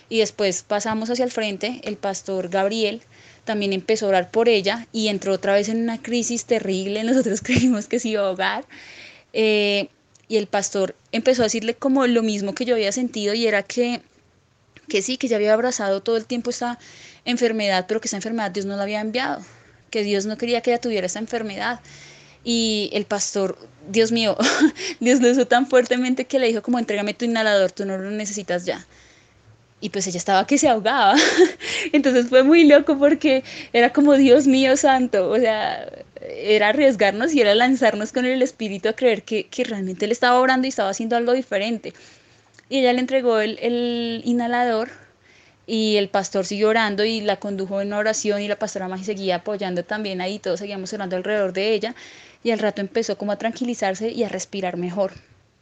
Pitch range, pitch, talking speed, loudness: 200-245 Hz, 220 Hz, 195 wpm, -20 LUFS